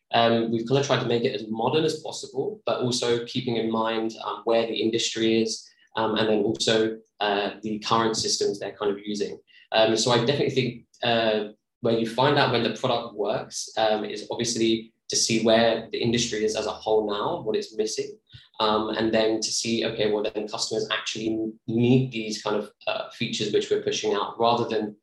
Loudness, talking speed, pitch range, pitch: -25 LUFS, 205 wpm, 110-120 Hz, 115 Hz